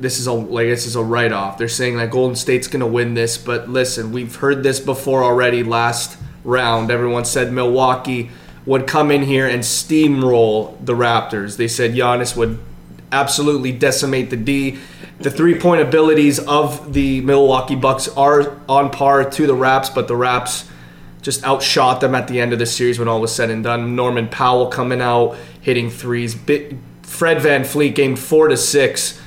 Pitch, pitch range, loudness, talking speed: 125 Hz, 120-140 Hz, -16 LUFS, 180 wpm